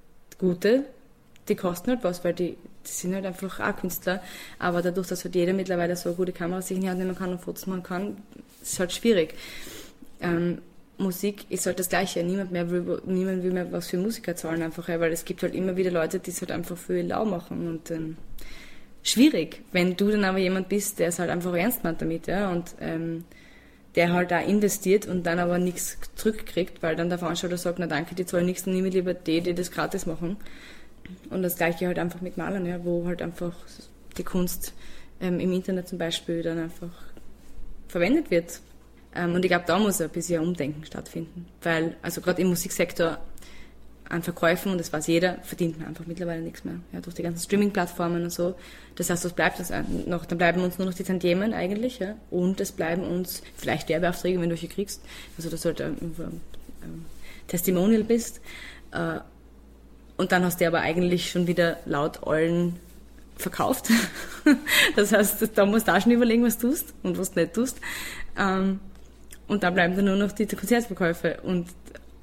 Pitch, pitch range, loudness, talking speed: 180 Hz, 170-190 Hz, -26 LUFS, 200 wpm